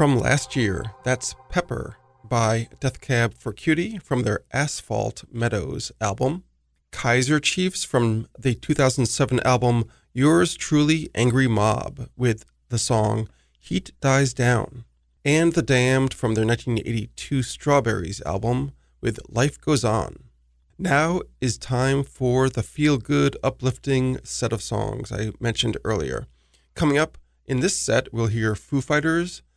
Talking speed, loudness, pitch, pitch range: 135 wpm, -23 LUFS, 125 Hz, 110-135 Hz